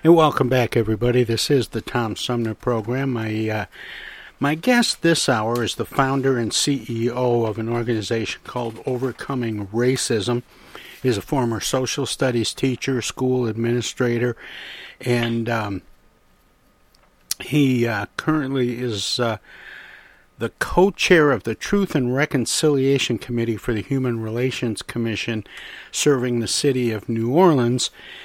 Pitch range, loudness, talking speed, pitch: 115-135 Hz, -21 LUFS, 130 wpm, 120 Hz